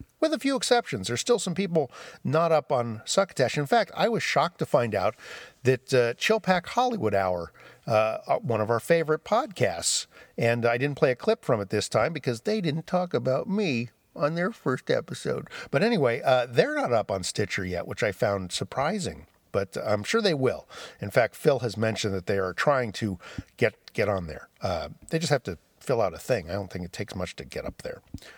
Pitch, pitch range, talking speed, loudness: 125 Hz, 105-165 Hz, 220 wpm, -27 LUFS